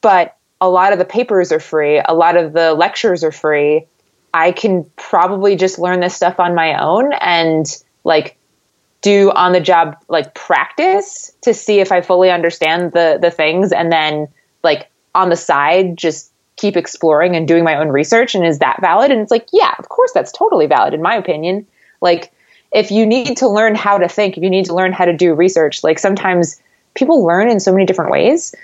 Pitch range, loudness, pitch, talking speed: 165-200 Hz, -13 LUFS, 180 Hz, 205 wpm